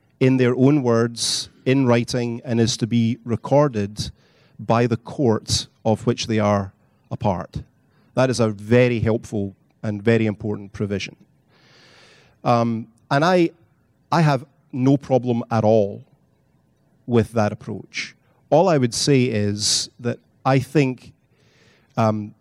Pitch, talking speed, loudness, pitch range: 115 Hz, 135 wpm, -20 LUFS, 110-130 Hz